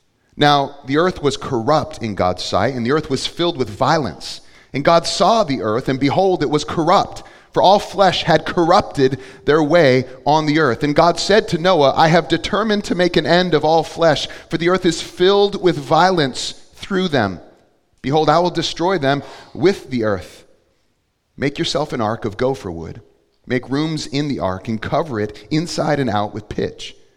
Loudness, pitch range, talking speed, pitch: -17 LUFS, 130-170 Hz, 190 wpm, 150 Hz